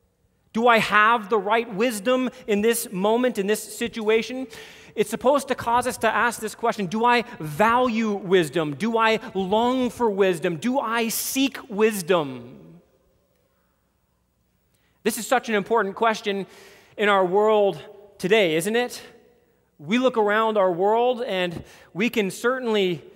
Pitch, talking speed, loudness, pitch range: 220 Hz, 145 wpm, -22 LUFS, 195-235 Hz